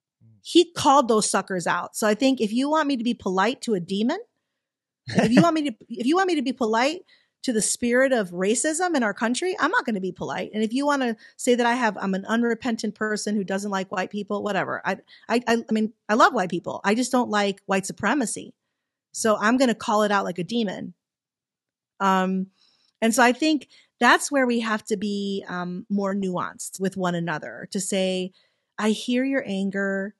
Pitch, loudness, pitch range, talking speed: 220 Hz, -23 LUFS, 195-250 Hz, 220 wpm